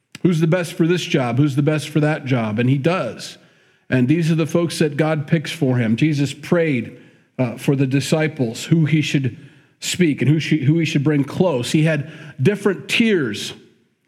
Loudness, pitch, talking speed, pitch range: -19 LUFS, 155 Hz, 200 wpm, 140-165 Hz